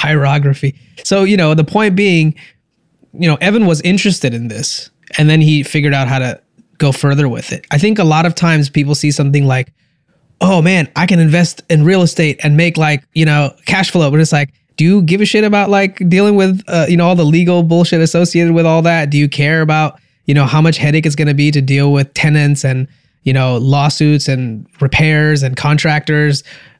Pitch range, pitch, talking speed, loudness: 145-170 Hz, 155 Hz, 220 wpm, -12 LUFS